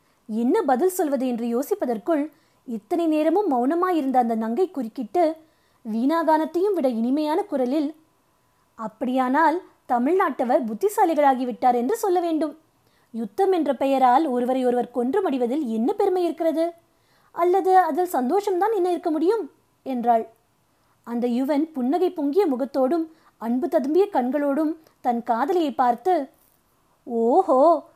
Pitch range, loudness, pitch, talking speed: 255-345 Hz, -22 LUFS, 300 Hz, 105 wpm